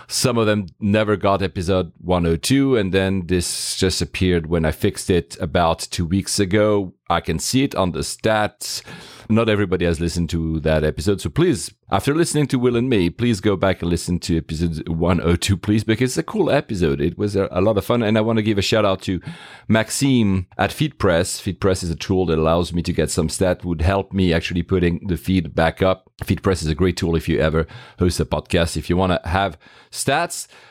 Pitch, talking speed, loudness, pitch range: 95 Hz, 215 wpm, -20 LUFS, 85-105 Hz